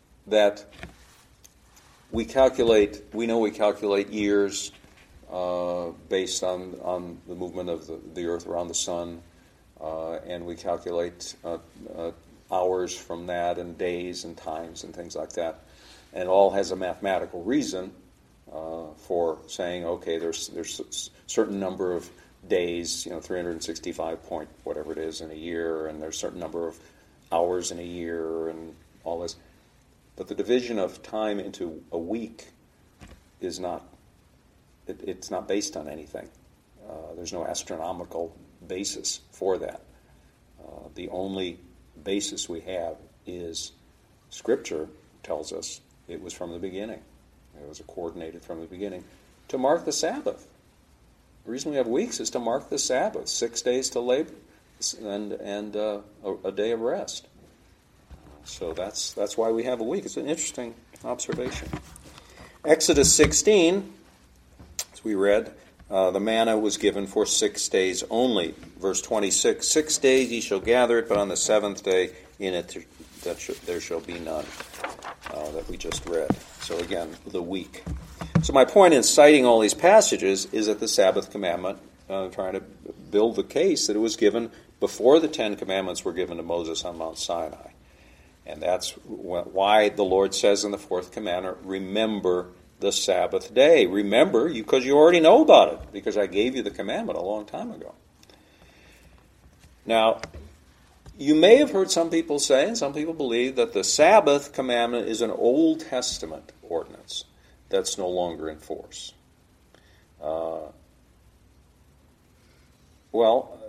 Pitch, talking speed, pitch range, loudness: 90 Hz, 160 wpm, 80-105 Hz, -25 LUFS